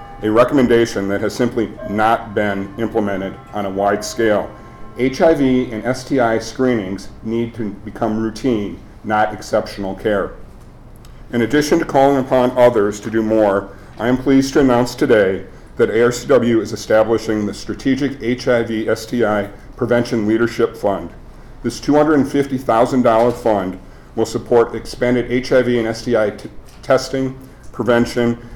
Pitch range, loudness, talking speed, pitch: 105-125 Hz, -17 LUFS, 130 wpm, 115 Hz